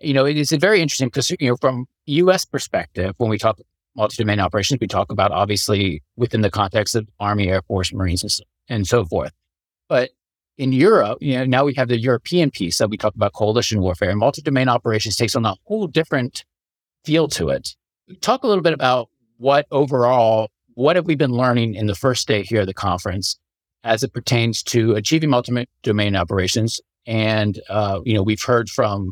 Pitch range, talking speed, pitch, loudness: 105-135 Hz, 190 wpm, 115 Hz, -19 LUFS